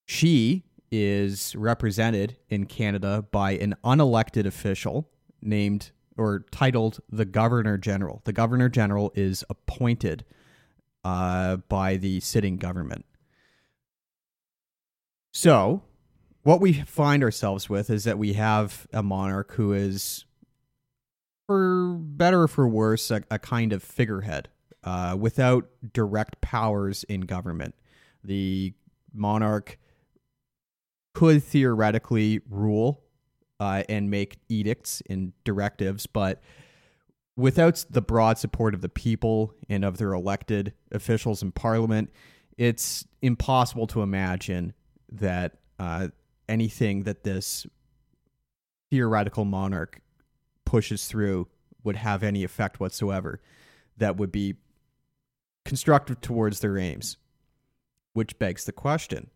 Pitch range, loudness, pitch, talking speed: 100-125 Hz, -26 LUFS, 110 Hz, 110 wpm